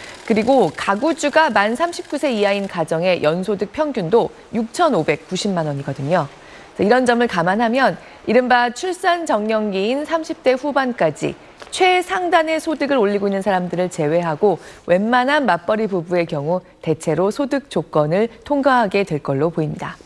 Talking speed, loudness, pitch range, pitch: 295 characters per minute, -18 LUFS, 180-280 Hz, 215 Hz